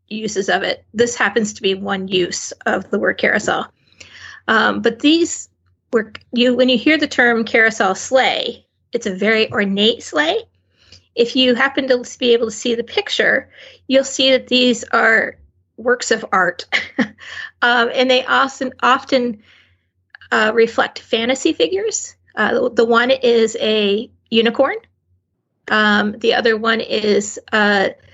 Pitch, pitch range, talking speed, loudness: 230 Hz, 205-255 Hz, 150 wpm, -16 LUFS